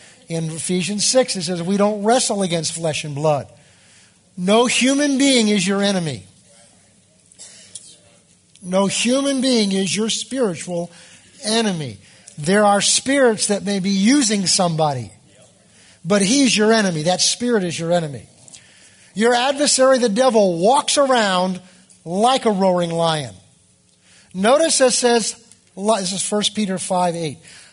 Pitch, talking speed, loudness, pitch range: 195 Hz, 130 wpm, -17 LUFS, 170-230 Hz